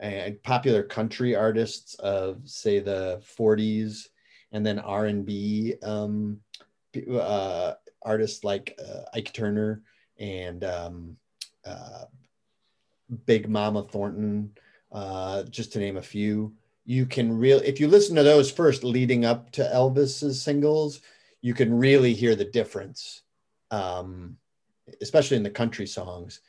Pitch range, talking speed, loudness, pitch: 105-125 Hz, 125 wpm, -25 LUFS, 110 Hz